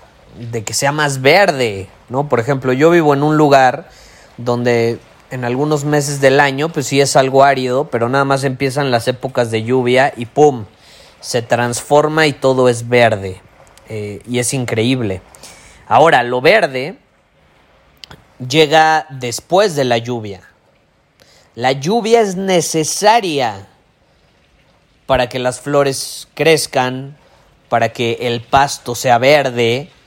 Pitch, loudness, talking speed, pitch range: 130 Hz, -14 LUFS, 135 wpm, 120-145 Hz